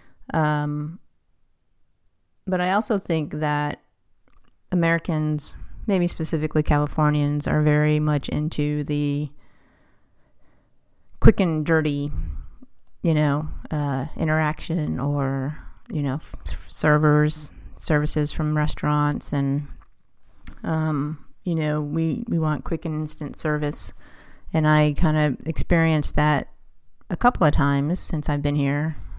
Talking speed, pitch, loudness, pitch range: 115 wpm, 150 Hz, -23 LUFS, 145-160 Hz